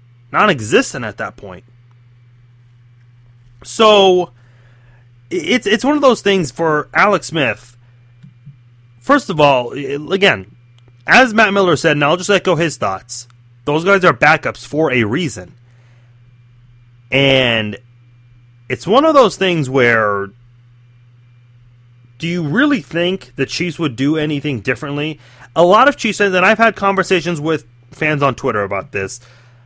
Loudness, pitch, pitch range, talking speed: -14 LUFS, 125 Hz, 120-170 Hz, 140 wpm